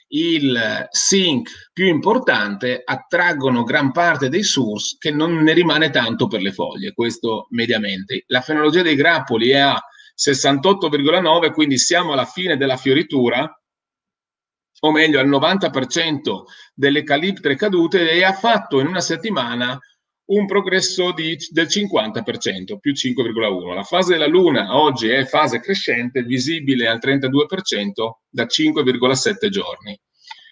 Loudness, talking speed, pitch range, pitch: -17 LUFS, 130 wpm, 130-185 Hz, 155 Hz